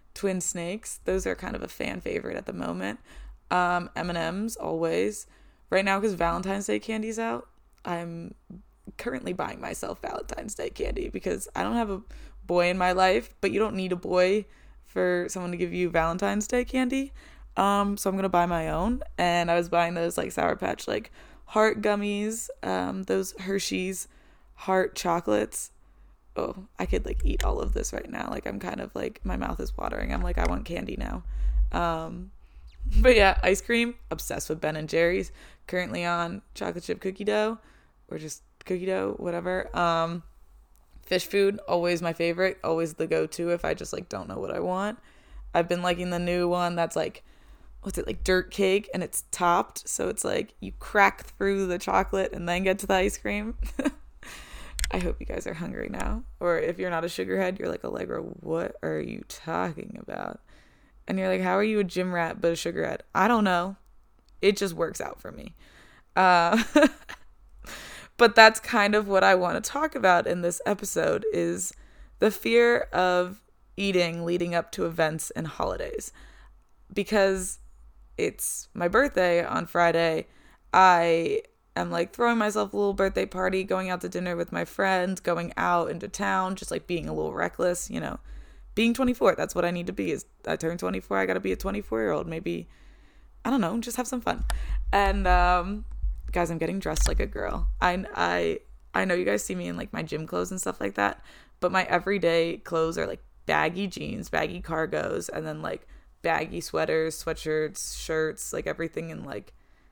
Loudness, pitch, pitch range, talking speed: -27 LUFS, 180 Hz, 165-200 Hz, 190 wpm